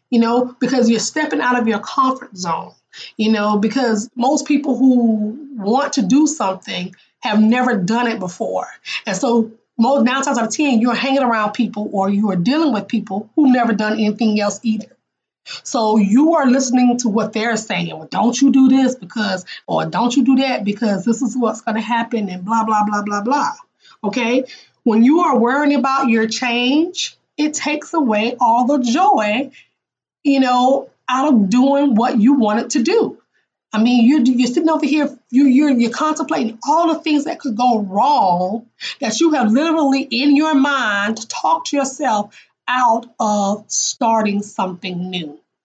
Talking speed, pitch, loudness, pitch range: 180 wpm, 240 Hz, -16 LUFS, 220-275 Hz